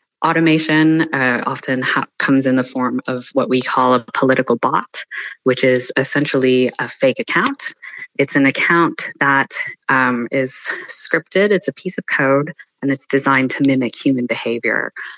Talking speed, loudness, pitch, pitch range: 160 wpm, -16 LUFS, 135 Hz, 125-145 Hz